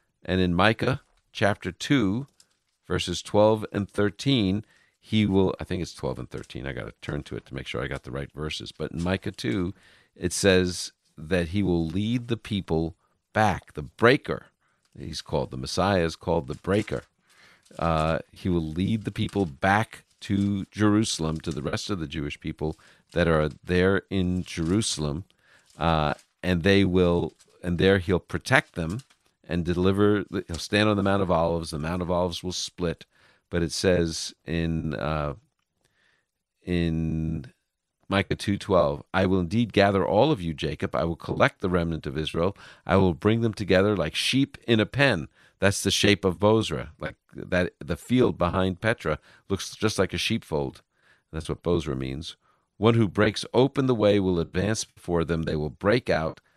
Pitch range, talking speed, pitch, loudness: 80-105 Hz, 170 wpm, 90 Hz, -26 LUFS